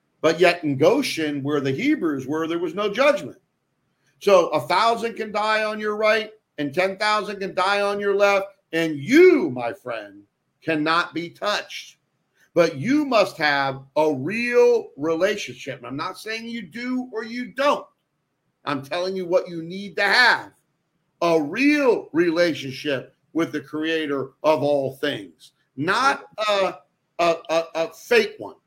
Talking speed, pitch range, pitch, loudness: 155 wpm, 155-220 Hz, 180 Hz, -22 LUFS